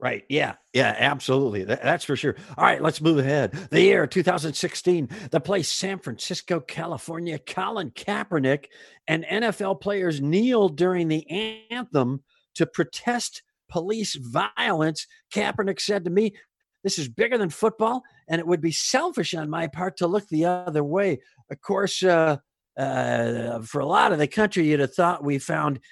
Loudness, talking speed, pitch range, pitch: -24 LUFS, 165 wpm, 150-200 Hz, 175 Hz